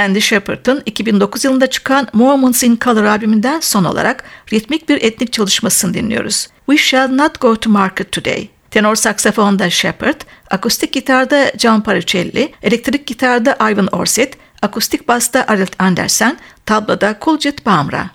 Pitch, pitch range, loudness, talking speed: 235 Hz, 210-265 Hz, -13 LUFS, 135 wpm